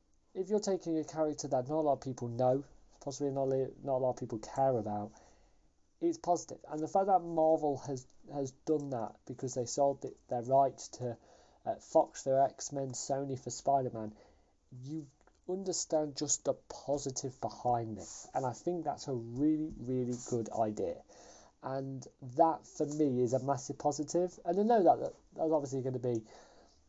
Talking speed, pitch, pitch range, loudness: 175 wpm, 135 Hz, 125-155 Hz, -35 LUFS